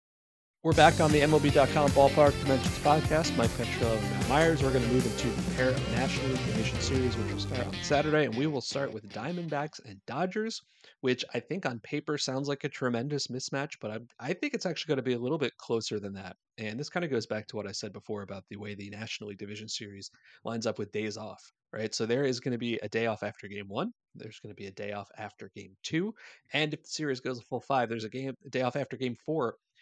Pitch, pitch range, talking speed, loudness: 125 Hz, 110-150 Hz, 255 wpm, -30 LUFS